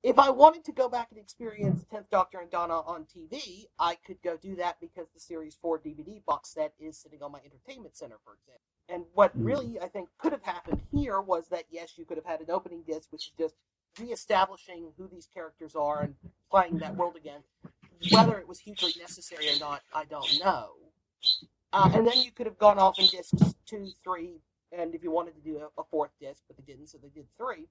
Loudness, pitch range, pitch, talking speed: -28 LUFS, 155-190 Hz, 175 Hz, 225 wpm